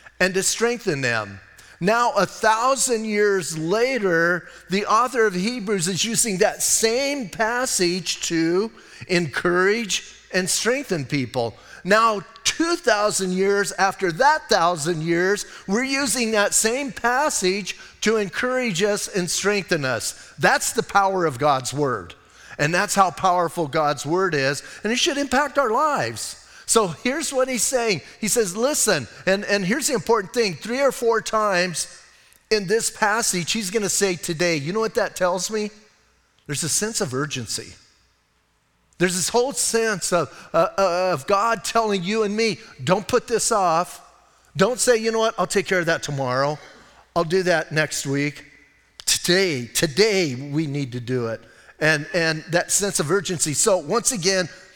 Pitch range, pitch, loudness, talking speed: 165-225 Hz, 190 Hz, -21 LUFS, 160 wpm